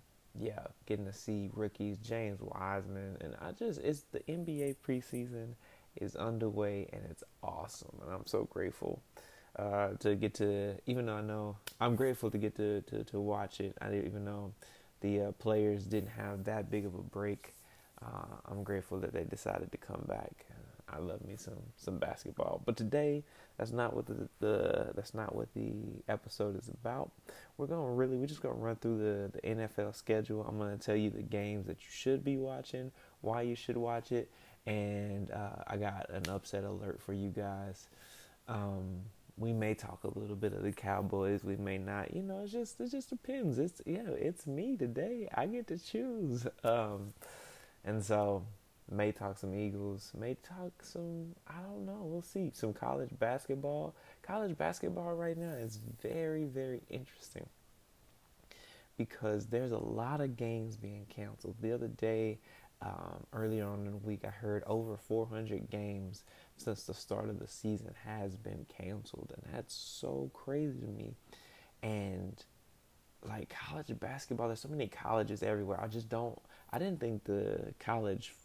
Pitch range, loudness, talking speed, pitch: 100-125 Hz, -40 LUFS, 180 wpm, 110 Hz